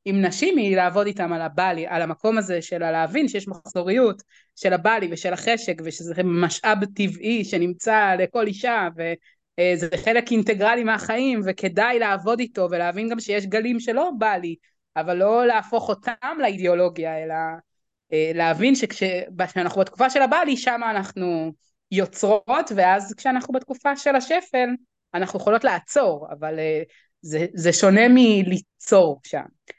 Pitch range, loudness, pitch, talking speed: 175-230 Hz, -21 LUFS, 195 Hz, 130 wpm